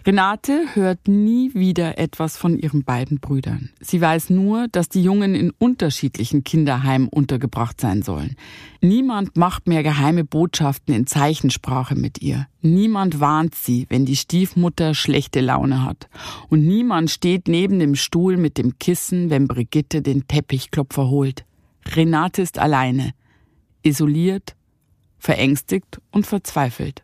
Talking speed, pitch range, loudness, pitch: 135 wpm, 135-180 Hz, -19 LUFS, 155 Hz